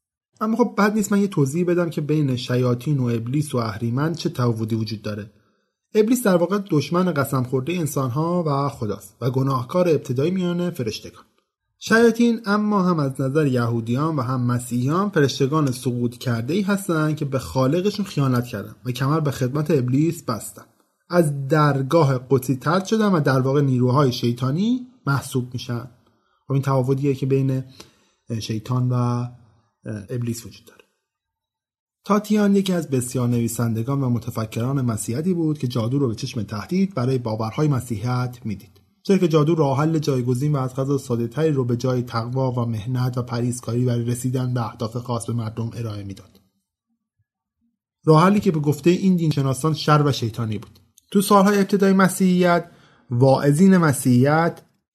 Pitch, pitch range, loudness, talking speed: 135 Hz, 120-165 Hz, -21 LUFS, 155 wpm